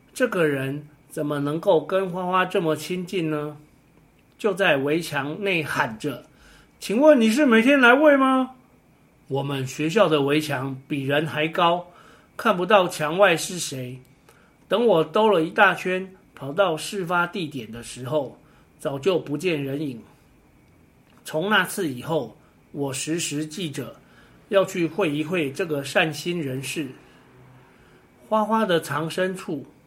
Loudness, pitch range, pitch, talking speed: -22 LUFS, 145-190 Hz, 160 Hz, 195 characters per minute